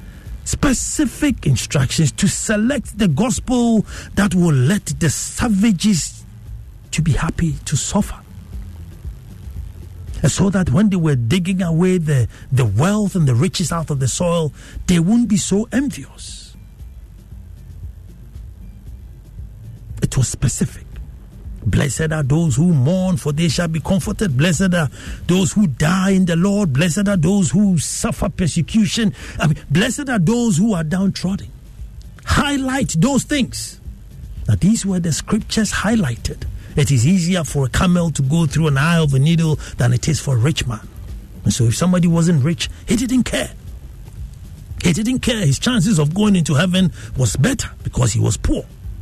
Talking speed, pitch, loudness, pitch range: 155 wpm, 160 Hz, -17 LUFS, 115-190 Hz